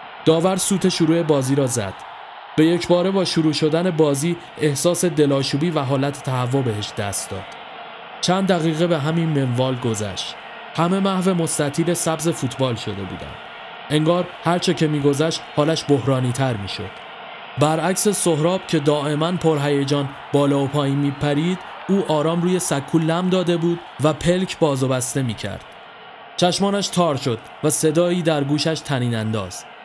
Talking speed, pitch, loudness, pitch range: 155 wpm, 155 Hz, -20 LUFS, 140-175 Hz